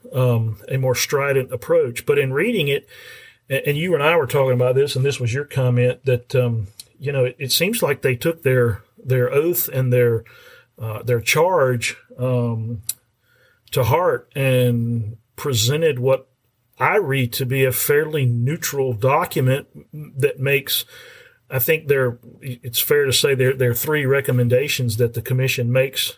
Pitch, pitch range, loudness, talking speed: 130 Hz, 120-140 Hz, -19 LUFS, 165 wpm